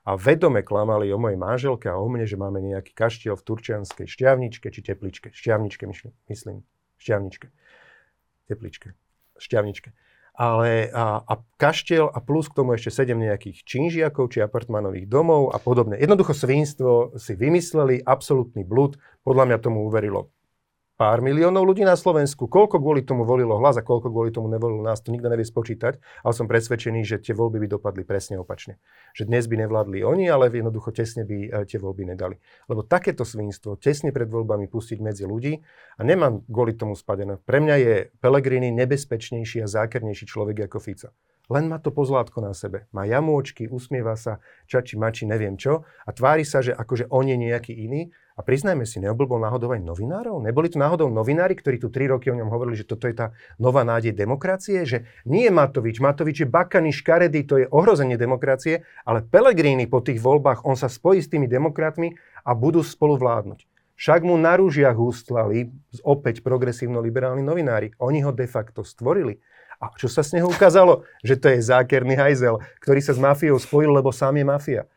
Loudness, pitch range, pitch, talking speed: -21 LUFS, 110-140 Hz, 125 Hz, 180 wpm